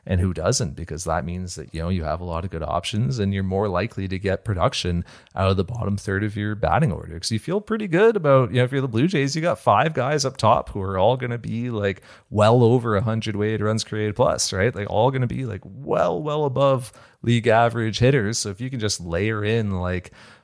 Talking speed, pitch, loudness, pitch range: 260 wpm, 105 Hz, -22 LUFS, 95-125 Hz